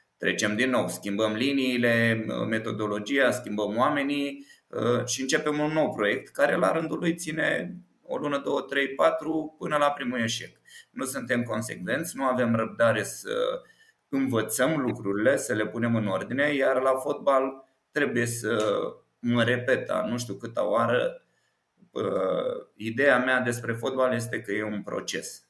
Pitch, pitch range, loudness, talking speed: 130 Hz, 115-150 Hz, -27 LUFS, 145 wpm